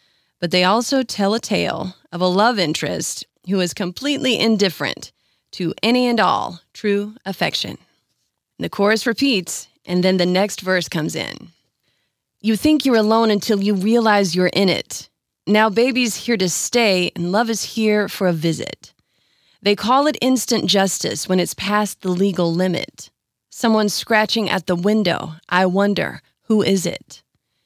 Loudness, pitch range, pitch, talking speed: -18 LUFS, 185-225 Hz, 205 Hz, 160 wpm